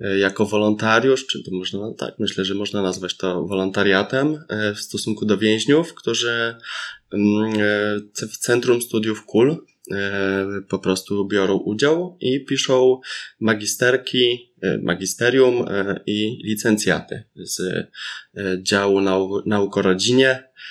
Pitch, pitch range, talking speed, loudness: 105 Hz, 100-120 Hz, 100 wpm, -20 LUFS